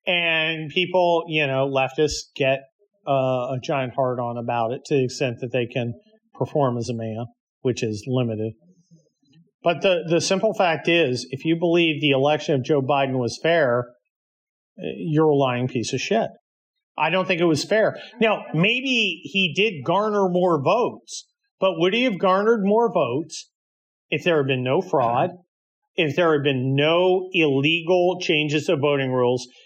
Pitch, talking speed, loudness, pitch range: 155 Hz, 170 wpm, -21 LUFS, 130-185 Hz